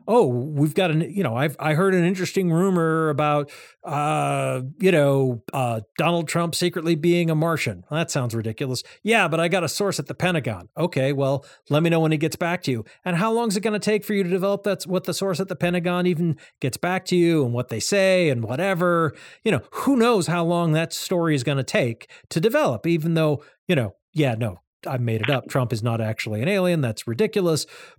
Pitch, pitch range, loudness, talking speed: 165 Hz, 135-180 Hz, -22 LUFS, 230 wpm